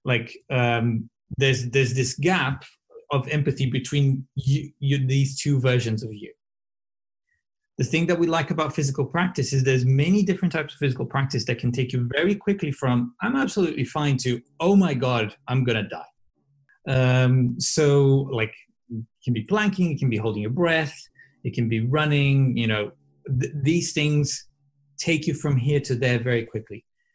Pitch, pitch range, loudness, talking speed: 140 Hz, 125-155 Hz, -23 LUFS, 175 wpm